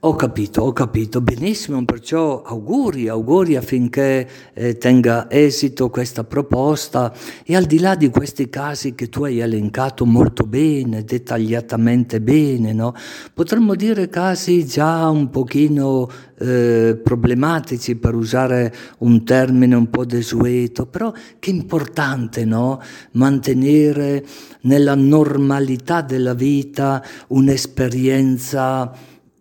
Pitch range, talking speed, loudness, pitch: 120-145 Hz, 110 wpm, -17 LUFS, 130 Hz